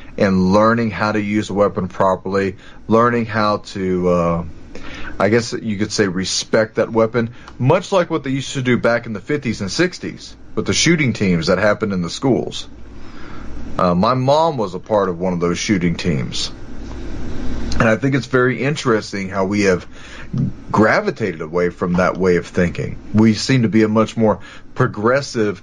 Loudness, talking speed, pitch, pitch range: -18 LUFS, 185 wpm, 105 Hz, 95-120 Hz